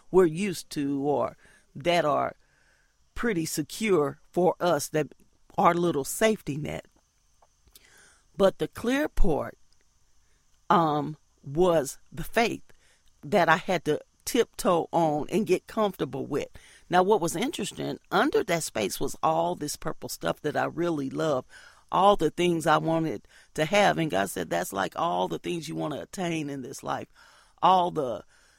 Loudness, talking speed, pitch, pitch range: -27 LUFS, 155 wpm, 160 Hz, 140-180 Hz